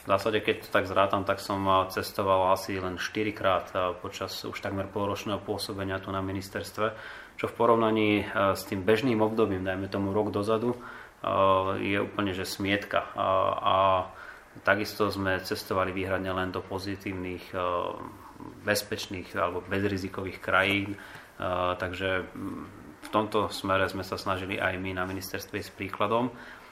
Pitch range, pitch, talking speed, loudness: 95-105 Hz, 95 Hz, 140 wpm, -29 LUFS